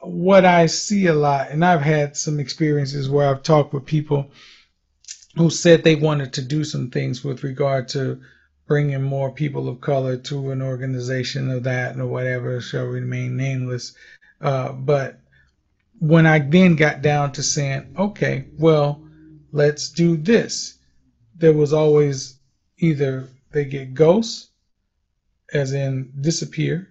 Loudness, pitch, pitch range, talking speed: -19 LUFS, 140 Hz, 130-155 Hz, 145 wpm